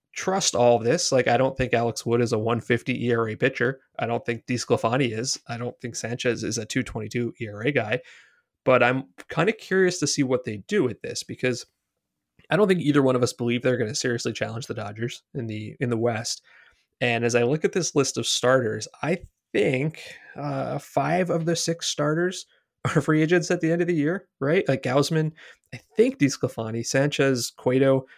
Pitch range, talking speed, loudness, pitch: 120-155 Hz, 205 wpm, -24 LUFS, 130 Hz